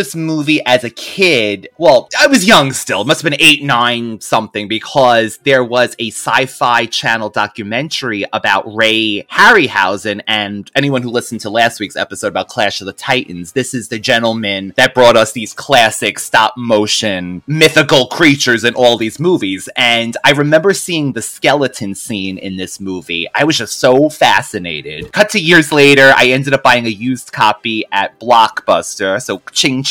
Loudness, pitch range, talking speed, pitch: -12 LUFS, 110-145 Hz, 170 wpm, 120 Hz